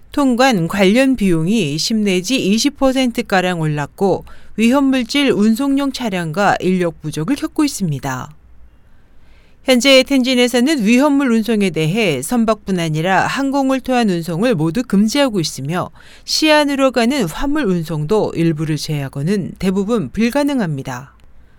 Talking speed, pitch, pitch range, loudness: 280 characters per minute, 215 Hz, 170-265 Hz, -16 LUFS